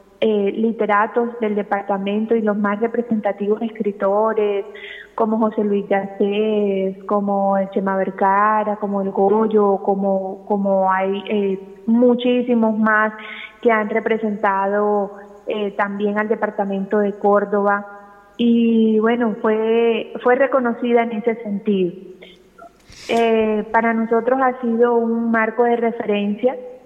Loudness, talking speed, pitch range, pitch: -19 LUFS, 115 wpm, 200-230 Hz, 215 Hz